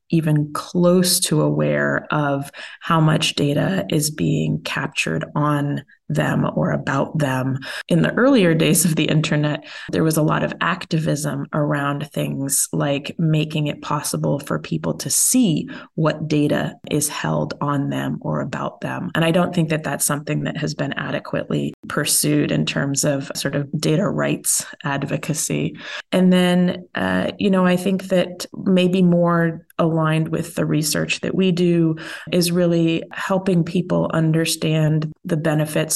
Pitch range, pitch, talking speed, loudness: 145-175 Hz, 155 Hz, 155 wpm, -20 LUFS